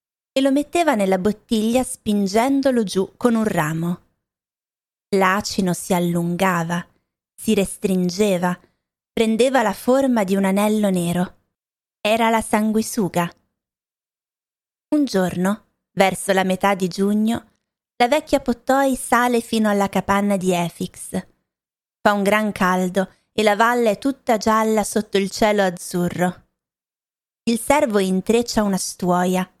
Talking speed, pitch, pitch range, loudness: 120 wpm, 205 Hz, 185-230 Hz, -20 LUFS